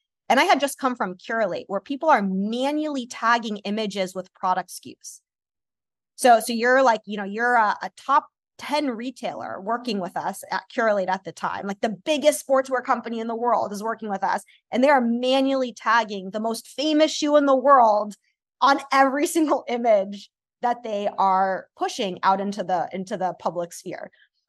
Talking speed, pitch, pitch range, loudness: 185 wpm, 230 Hz, 200-270 Hz, -23 LUFS